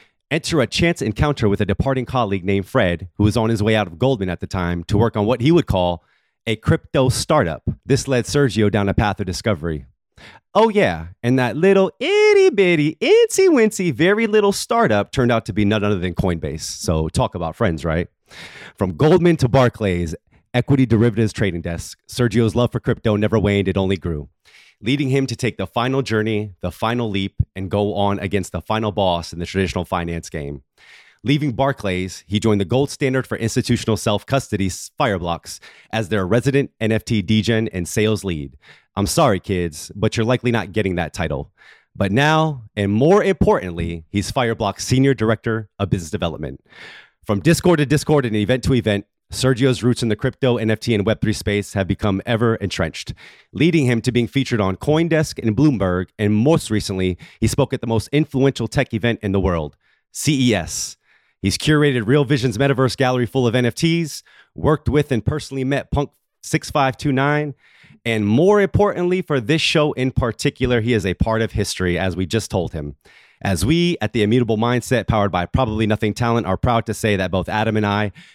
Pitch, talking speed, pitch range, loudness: 110 Hz, 185 wpm, 100-135 Hz, -19 LUFS